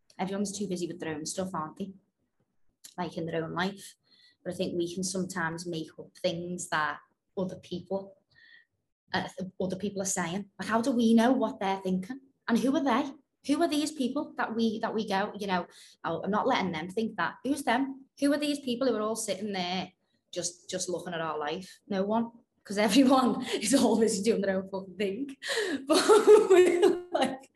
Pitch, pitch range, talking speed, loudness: 205 Hz, 185-265 Hz, 195 wpm, -29 LUFS